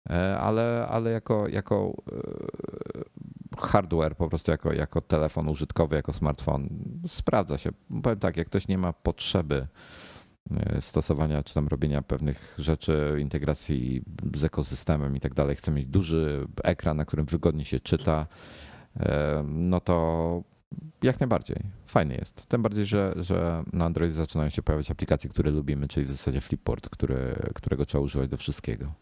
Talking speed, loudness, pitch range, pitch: 145 wpm, -28 LUFS, 75-95 Hz, 80 Hz